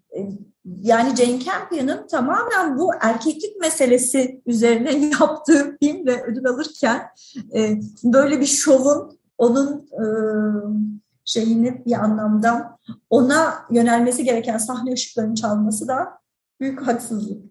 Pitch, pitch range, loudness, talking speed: 245 Hz, 225-285 Hz, -19 LUFS, 100 wpm